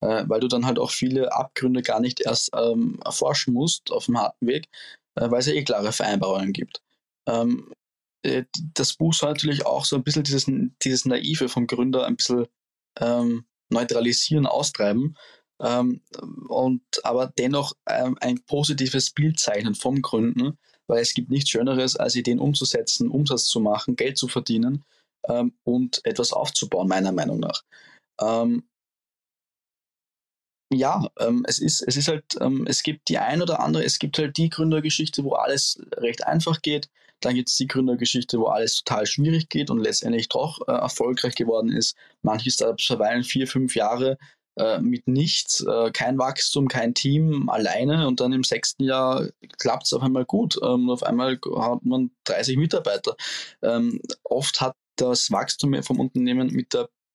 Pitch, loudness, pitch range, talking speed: 130 Hz, -23 LUFS, 120-155 Hz, 170 wpm